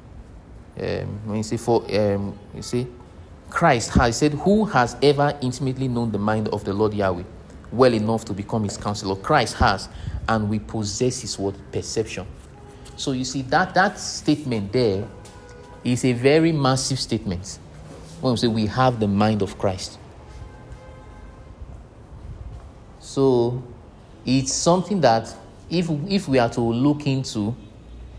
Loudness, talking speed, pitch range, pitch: -22 LUFS, 145 wpm, 100-130 Hz, 115 Hz